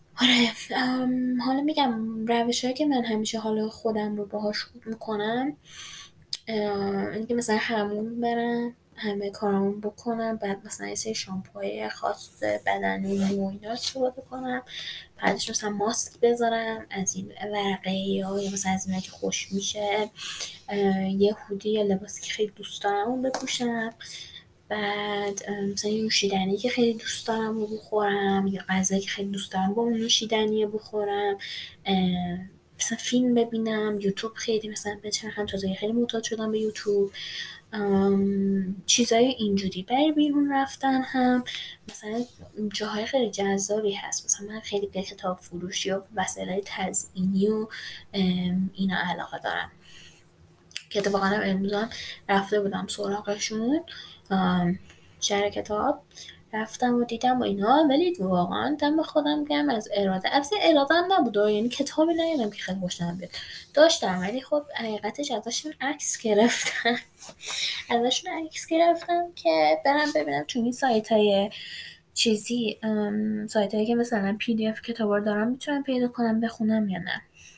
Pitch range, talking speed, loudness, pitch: 200-235 Hz, 140 wpm, -25 LUFS, 215 Hz